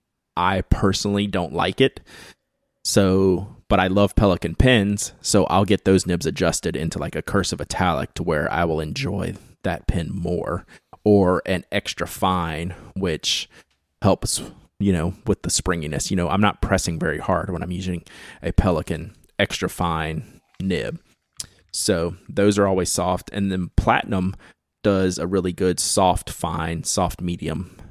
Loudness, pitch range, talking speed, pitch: -22 LUFS, 85-100 Hz, 155 wpm, 95 Hz